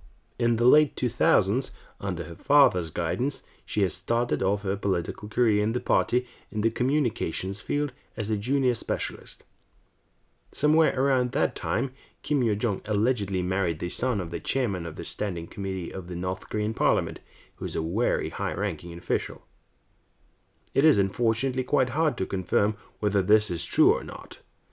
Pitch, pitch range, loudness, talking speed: 105 Hz, 95-120 Hz, -26 LUFS, 165 wpm